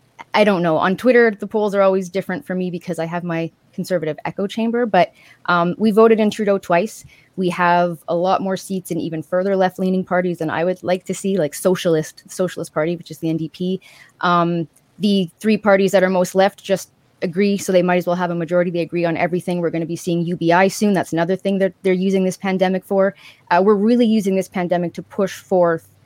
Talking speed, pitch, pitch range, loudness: 225 wpm, 180 Hz, 170-195 Hz, -18 LUFS